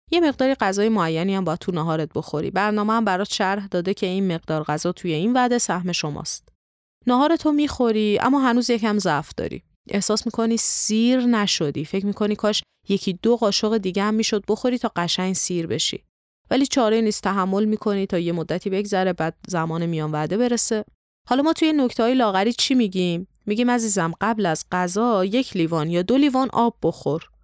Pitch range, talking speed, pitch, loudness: 175-235 Hz, 180 wpm, 205 Hz, -21 LUFS